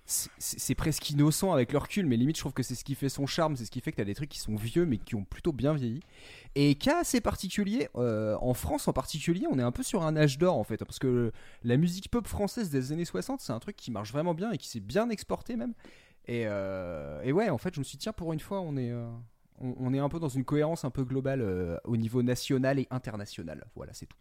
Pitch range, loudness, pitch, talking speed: 120-170 Hz, -31 LUFS, 135 Hz, 280 wpm